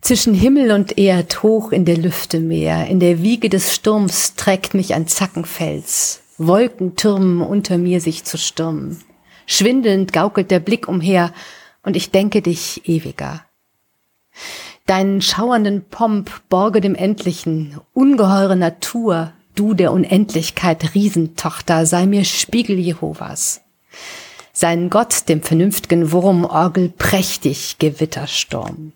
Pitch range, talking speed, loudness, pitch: 165-200 Hz, 120 wpm, -16 LUFS, 185 Hz